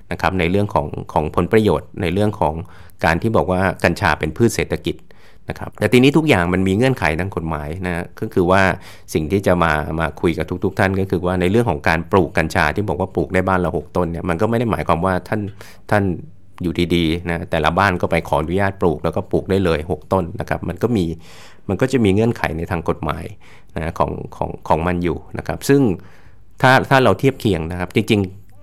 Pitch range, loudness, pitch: 85-100 Hz, -18 LUFS, 90 Hz